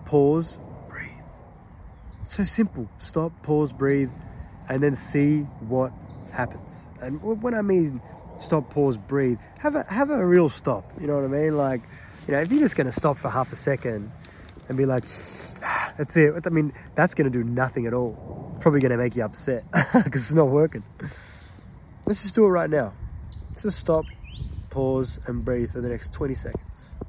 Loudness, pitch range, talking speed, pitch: -24 LUFS, 120-160 Hz, 185 wpm, 135 Hz